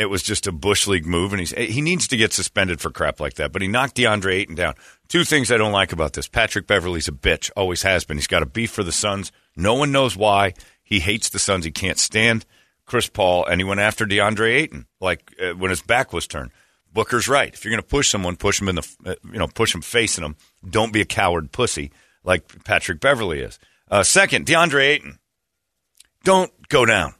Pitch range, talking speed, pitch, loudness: 90-115 Hz, 235 wpm, 100 Hz, -19 LUFS